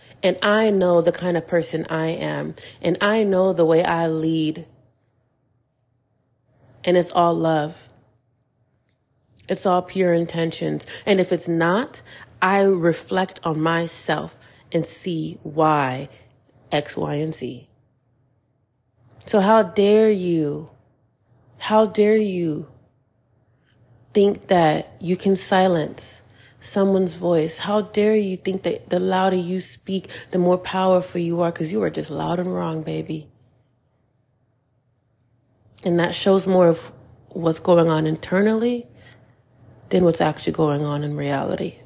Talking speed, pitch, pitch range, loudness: 130 wpm, 160 Hz, 125-180 Hz, -20 LUFS